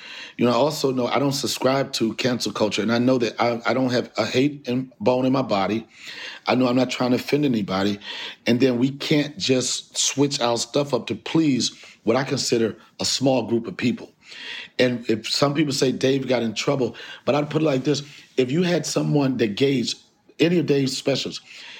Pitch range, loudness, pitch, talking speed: 120-140 Hz, -22 LUFS, 130 Hz, 215 wpm